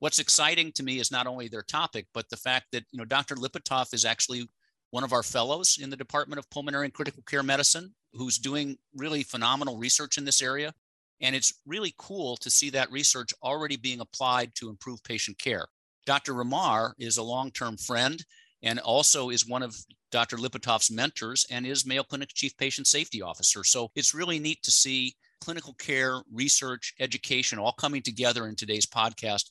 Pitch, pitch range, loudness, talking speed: 130 Hz, 120-140 Hz, -27 LUFS, 190 wpm